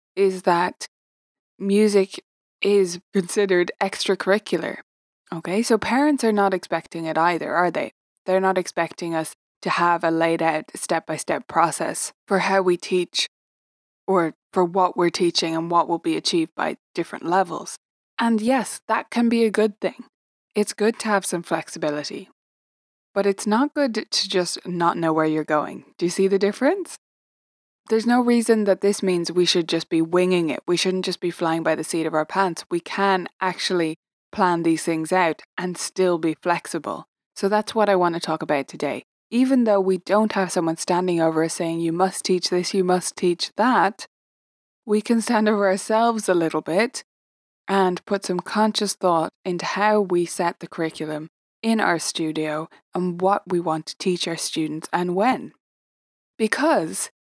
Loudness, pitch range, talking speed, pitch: -22 LUFS, 170-205 Hz, 180 wpm, 185 Hz